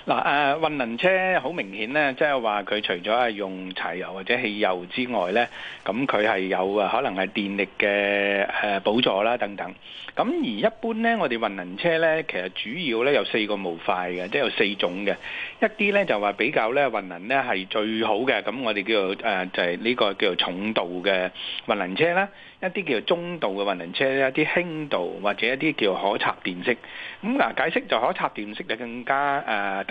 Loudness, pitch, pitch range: -24 LUFS, 120 Hz, 100-160 Hz